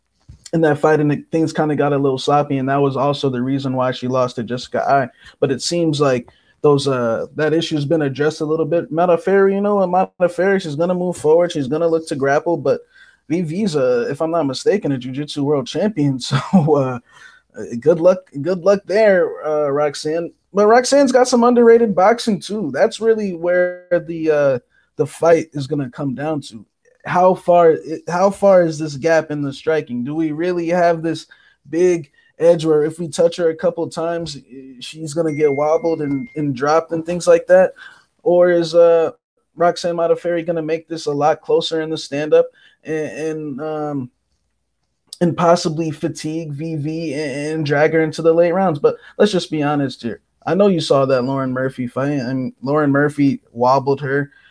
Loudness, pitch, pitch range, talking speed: -17 LUFS, 160 Hz, 145-175 Hz, 195 wpm